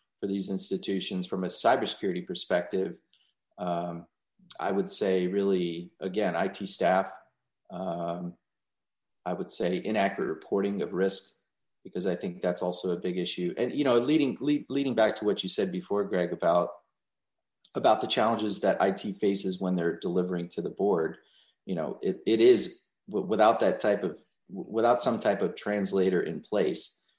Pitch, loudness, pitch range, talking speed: 95 Hz, -28 LUFS, 90-100 Hz, 160 wpm